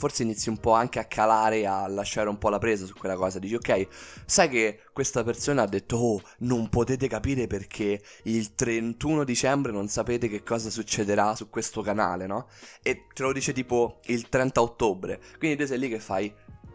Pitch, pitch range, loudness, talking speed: 115 Hz, 105-120 Hz, -27 LUFS, 195 wpm